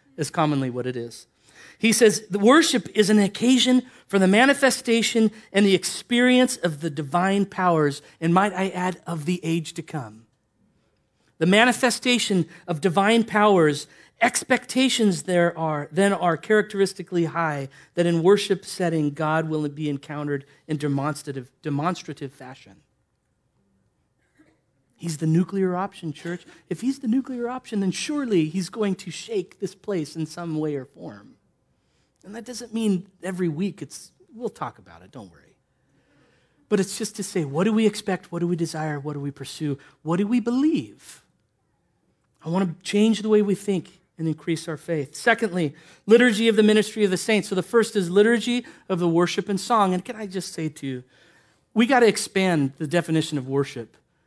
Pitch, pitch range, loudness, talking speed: 185 Hz, 155-215 Hz, -23 LUFS, 175 wpm